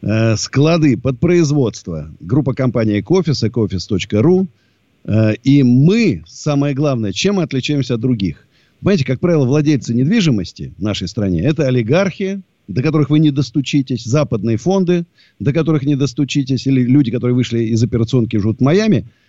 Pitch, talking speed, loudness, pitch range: 135 Hz, 145 wpm, -15 LUFS, 115-155 Hz